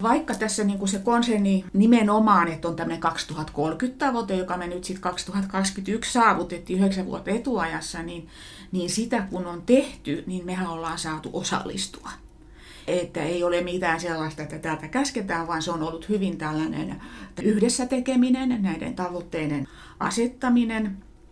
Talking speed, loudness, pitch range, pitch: 140 wpm, -25 LUFS, 165-220 Hz, 185 Hz